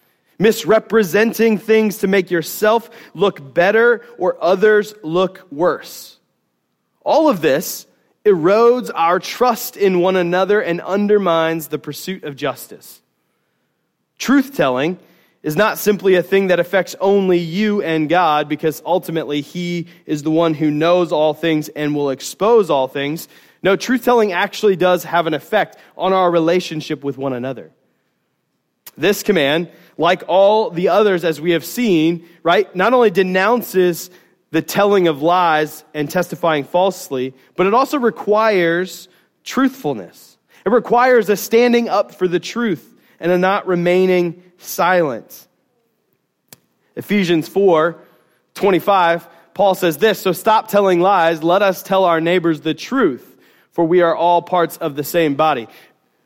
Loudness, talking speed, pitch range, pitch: -16 LUFS, 140 wpm, 160-205 Hz, 180 Hz